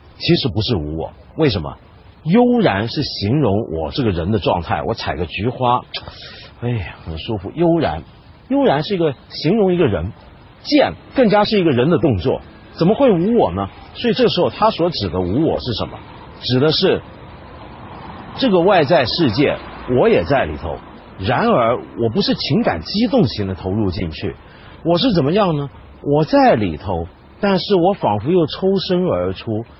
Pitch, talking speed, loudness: 135 Hz, 245 characters per minute, -17 LUFS